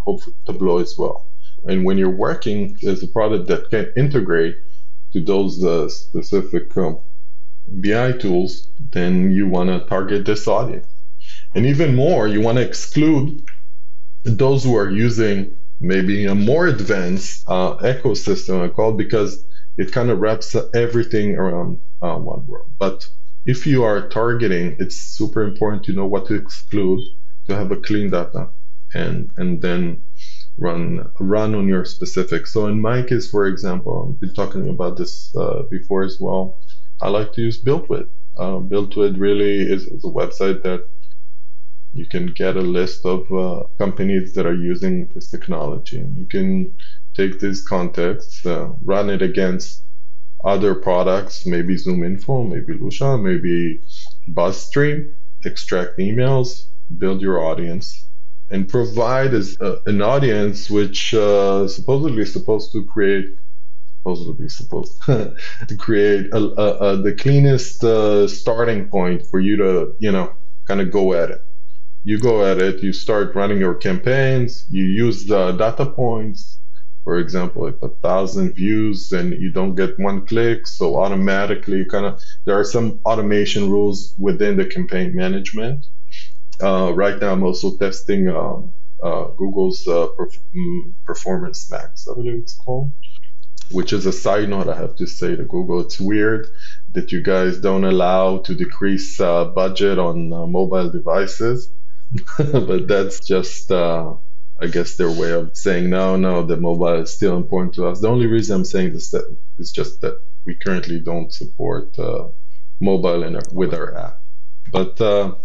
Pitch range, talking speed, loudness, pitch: 95-135 Hz, 155 wpm, -20 LUFS, 105 Hz